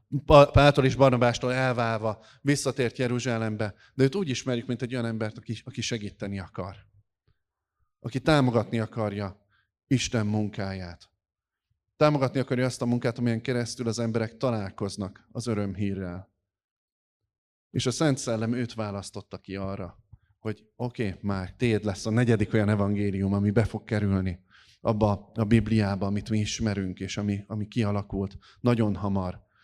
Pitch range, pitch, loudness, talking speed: 100-120 Hz, 110 Hz, -27 LUFS, 140 wpm